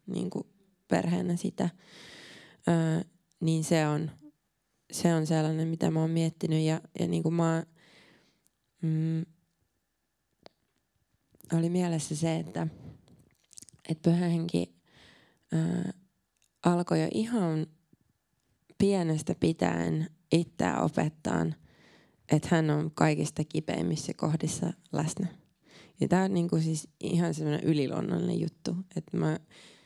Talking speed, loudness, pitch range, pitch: 95 wpm, -30 LUFS, 155-175 Hz, 165 Hz